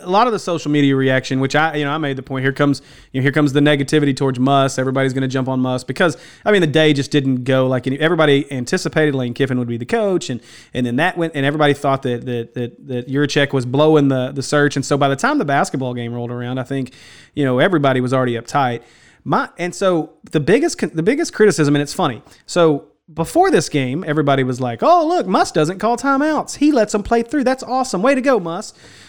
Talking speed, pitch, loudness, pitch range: 250 wpm, 145 Hz, -17 LUFS, 130-170 Hz